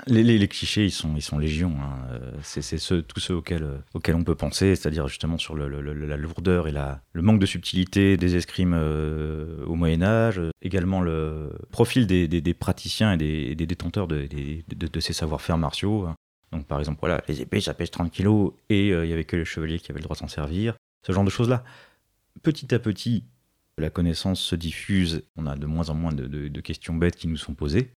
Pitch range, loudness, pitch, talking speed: 75-95 Hz, -25 LUFS, 85 Hz, 235 wpm